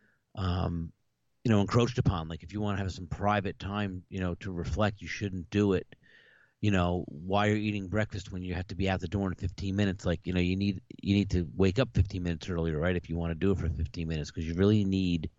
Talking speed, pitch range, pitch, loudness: 255 wpm, 85-100 Hz, 95 Hz, -31 LUFS